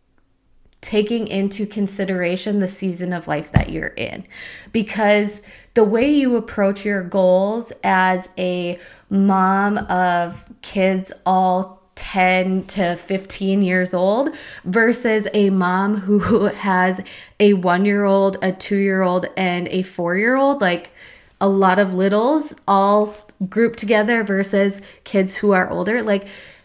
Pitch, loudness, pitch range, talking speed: 195 Hz, -18 LUFS, 185-210 Hz, 120 wpm